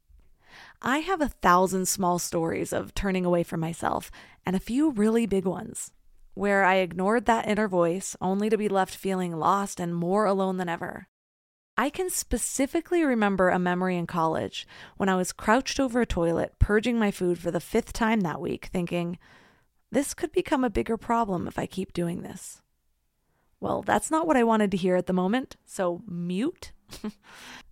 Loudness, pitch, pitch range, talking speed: -26 LUFS, 195 Hz, 175-230 Hz, 180 wpm